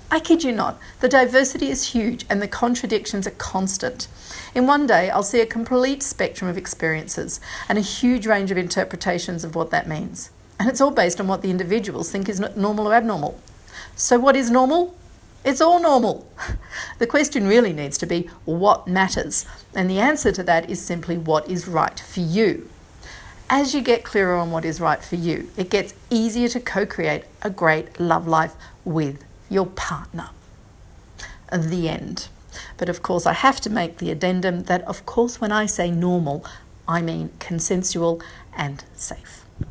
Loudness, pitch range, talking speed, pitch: -21 LUFS, 170-235 Hz, 180 wpm, 190 Hz